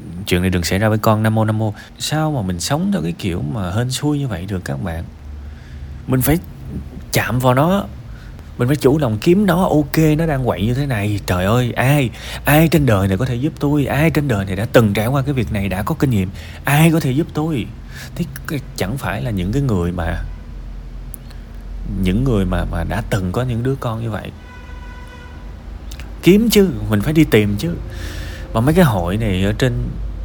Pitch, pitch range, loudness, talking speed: 110 Hz, 90-140 Hz, -17 LUFS, 215 wpm